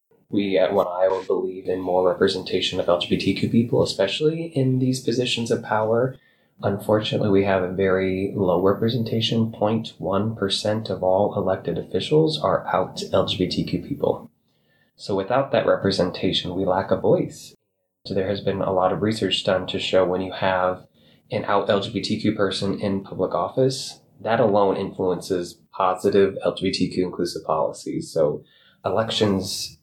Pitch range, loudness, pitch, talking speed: 95-115 Hz, -22 LUFS, 100 Hz, 145 wpm